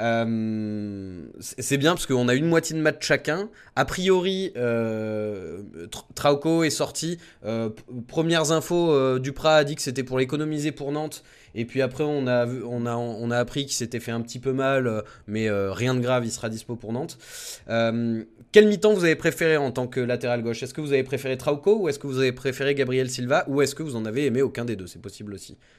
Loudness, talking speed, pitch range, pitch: -24 LUFS, 220 wpm, 115-150 Hz, 130 Hz